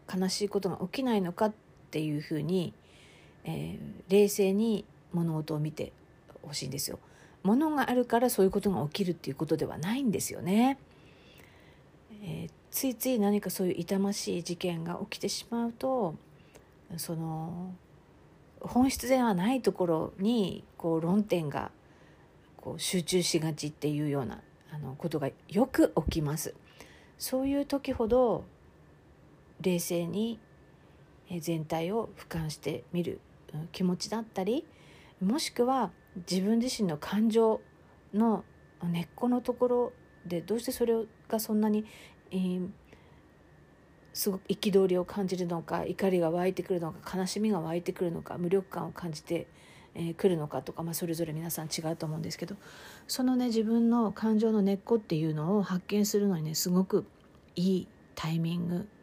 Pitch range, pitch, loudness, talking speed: 170-215 Hz, 185 Hz, -31 LUFS, 295 characters per minute